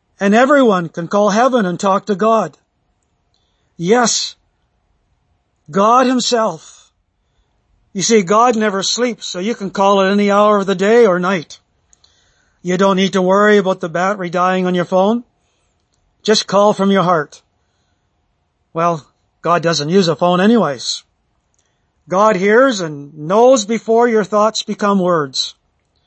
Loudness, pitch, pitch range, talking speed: -14 LUFS, 195 Hz, 160-215 Hz, 145 wpm